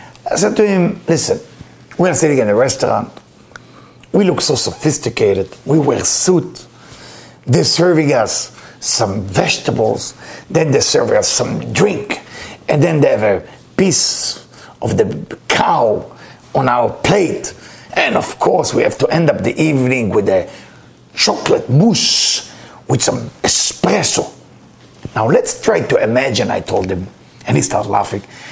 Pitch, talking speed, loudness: 175 Hz, 145 wpm, -14 LUFS